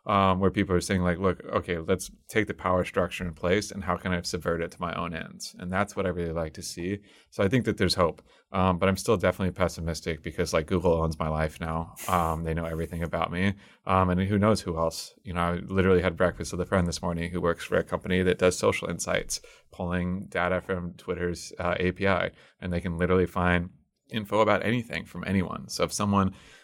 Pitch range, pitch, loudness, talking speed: 85-95 Hz, 90 Hz, -28 LUFS, 230 wpm